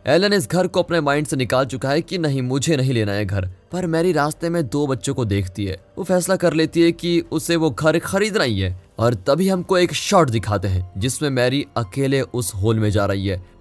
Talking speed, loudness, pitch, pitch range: 240 wpm, -20 LUFS, 140 Hz, 110-170 Hz